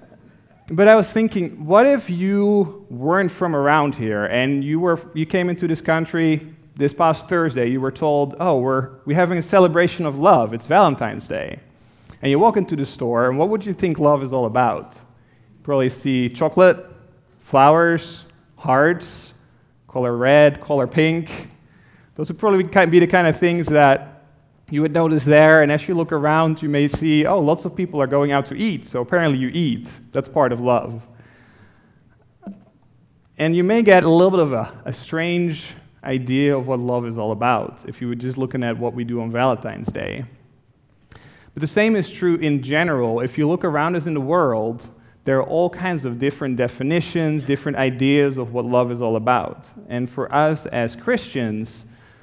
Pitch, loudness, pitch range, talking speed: 145 Hz, -18 LUFS, 125-170 Hz, 185 wpm